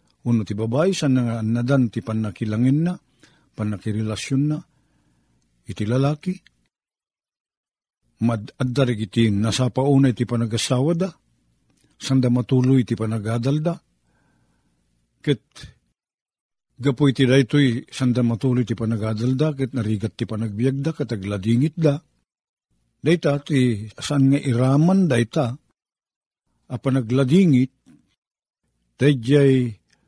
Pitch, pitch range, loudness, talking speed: 125 Hz, 110-140 Hz, -21 LUFS, 100 wpm